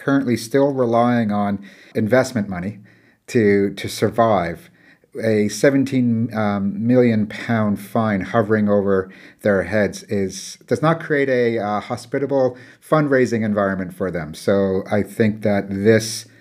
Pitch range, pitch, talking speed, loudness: 100-125 Hz, 110 Hz, 130 wpm, -19 LUFS